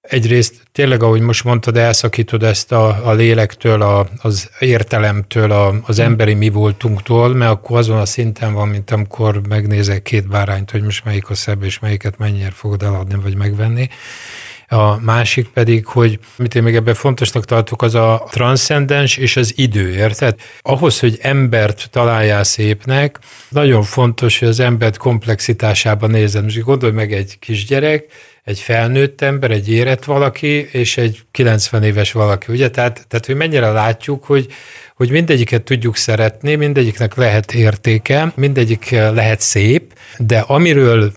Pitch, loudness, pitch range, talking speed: 115 Hz, -13 LUFS, 105-125 Hz, 155 wpm